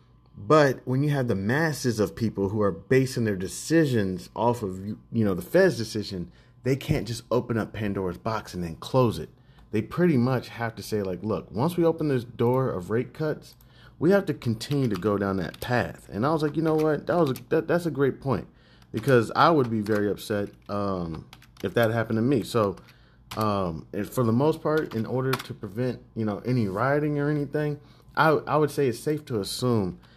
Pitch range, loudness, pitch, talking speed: 105-145 Hz, -26 LUFS, 120 Hz, 215 wpm